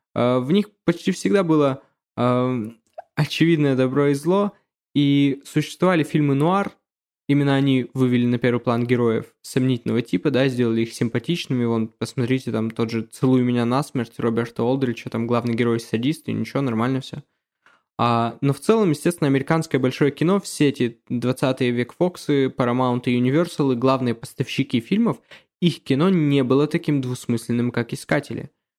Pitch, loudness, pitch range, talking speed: 130 Hz, -21 LUFS, 120-150 Hz, 155 wpm